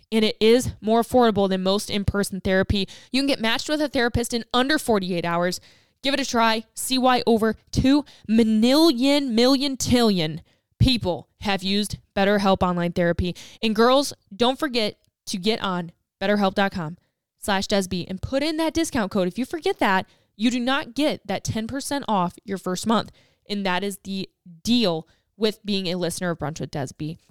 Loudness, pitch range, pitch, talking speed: -23 LUFS, 190-250 Hz, 215 Hz, 175 wpm